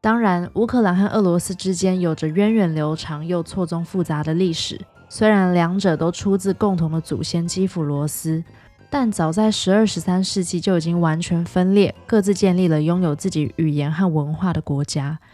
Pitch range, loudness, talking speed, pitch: 160-195 Hz, -20 LUFS, 290 characters per minute, 175 Hz